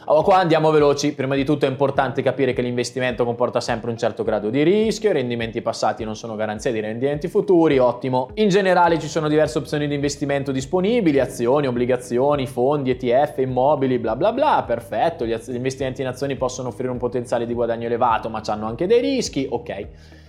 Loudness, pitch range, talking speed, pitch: -20 LUFS, 120-145 Hz, 190 wpm, 130 Hz